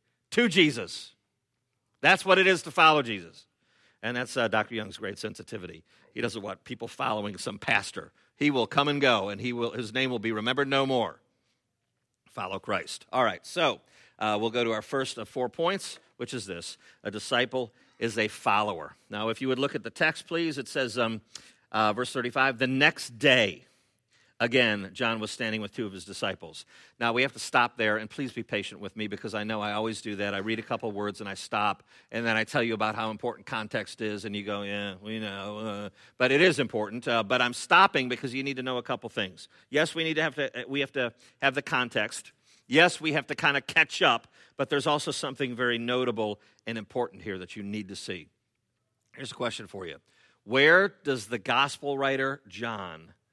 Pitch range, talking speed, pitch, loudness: 110-135 Hz, 215 wpm, 120 Hz, -28 LUFS